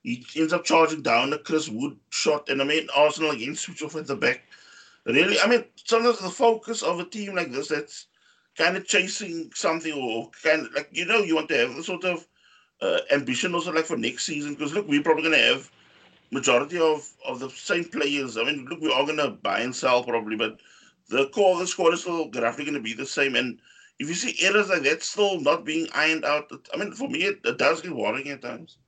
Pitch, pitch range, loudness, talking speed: 160 Hz, 145-195 Hz, -24 LUFS, 240 wpm